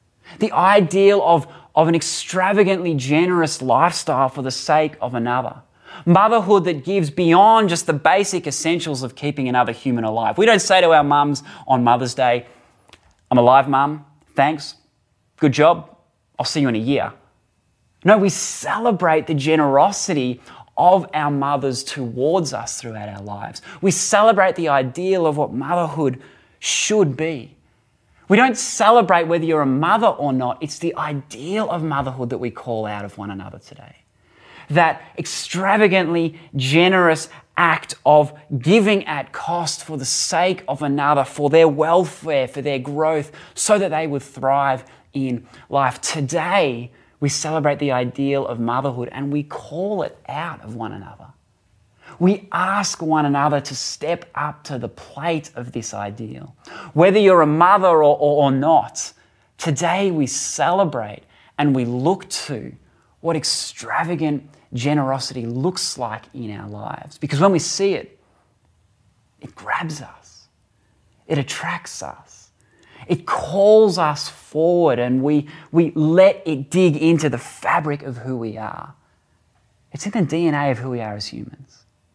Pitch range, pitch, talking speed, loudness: 130-170 Hz, 145 Hz, 150 wpm, -18 LUFS